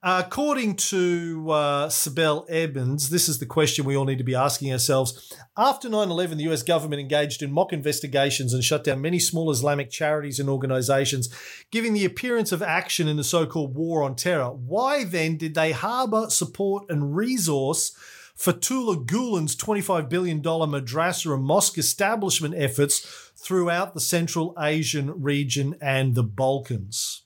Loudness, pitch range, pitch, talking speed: -24 LUFS, 140-180 Hz, 155 Hz, 155 wpm